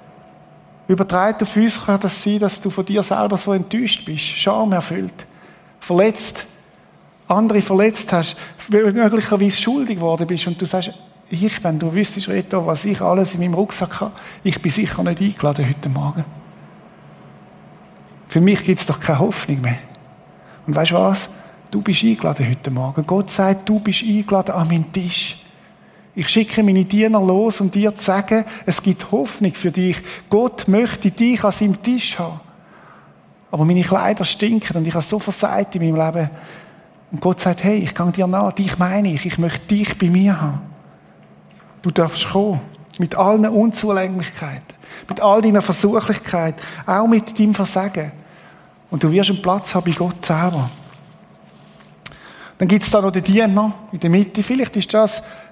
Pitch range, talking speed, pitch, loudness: 170-210 Hz, 170 wpm, 190 Hz, -17 LUFS